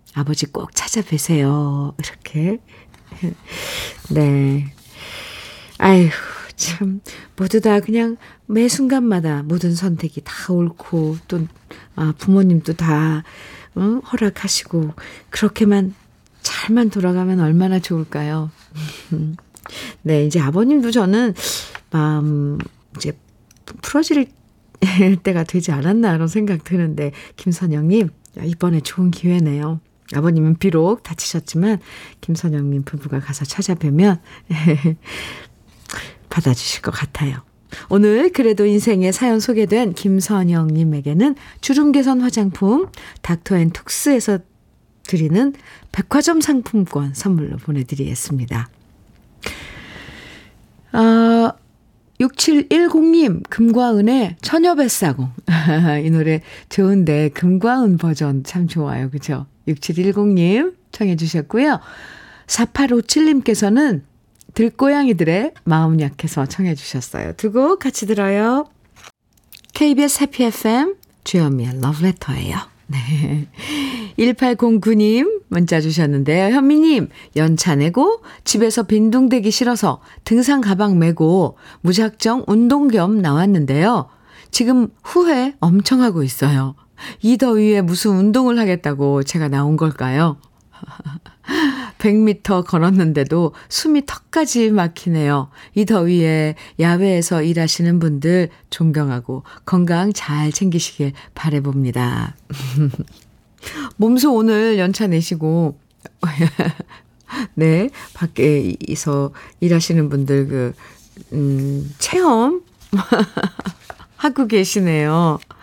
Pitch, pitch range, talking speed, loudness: 180 Hz, 150-220 Hz, 220 characters per minute, -17 LUFS